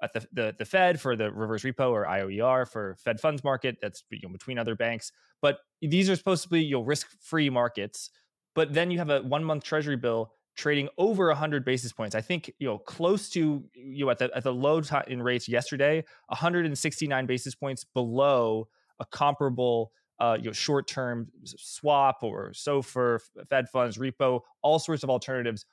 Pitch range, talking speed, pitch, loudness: 120-150 Hz, 195 wpm, 135 Hz, -28 LUFS